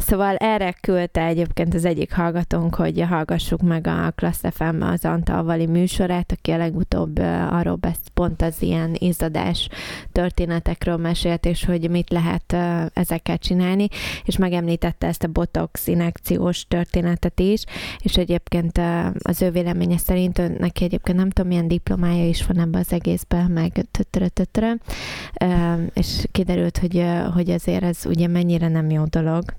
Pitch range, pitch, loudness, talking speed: 165-180 Hz, 175 Hz, -21 LUFS, 140 wpm